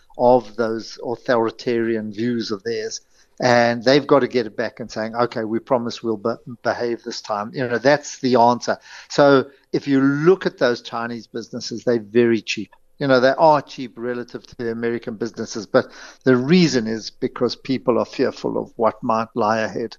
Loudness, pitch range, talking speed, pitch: -20 LUFS, 115-130 Hz, 185 wpm, 120 Hz